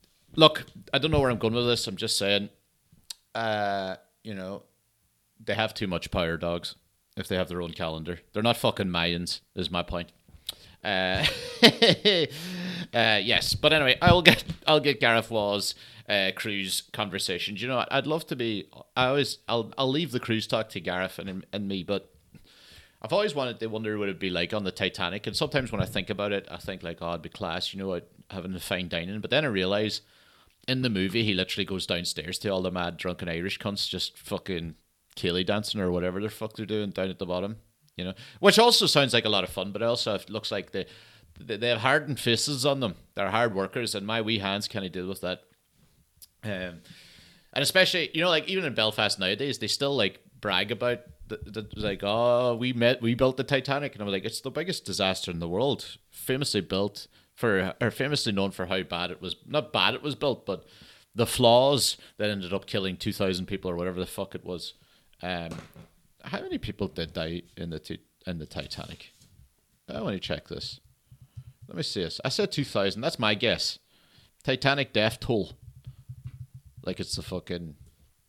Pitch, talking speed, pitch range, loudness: 105 Hz, 205 wpm, 90-120 Hz, -27 LUFS